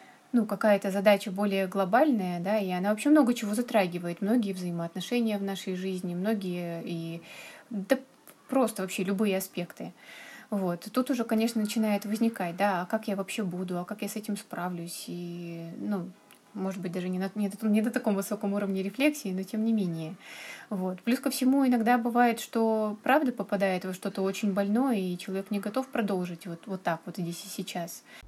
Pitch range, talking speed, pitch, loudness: 185-225 Hz, 185 wpm, 200 Hz, -29 LUFS